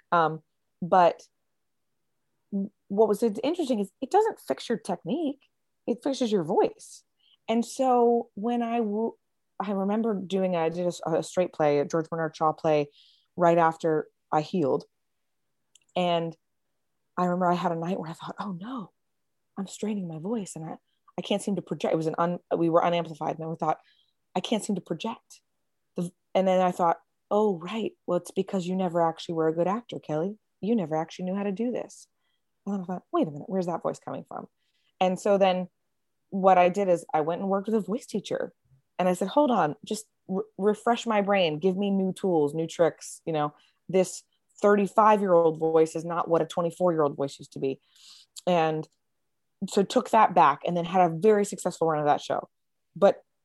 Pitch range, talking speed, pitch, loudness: 165-210 Hz, 200 wpm, 185 Hz, -27 LUFS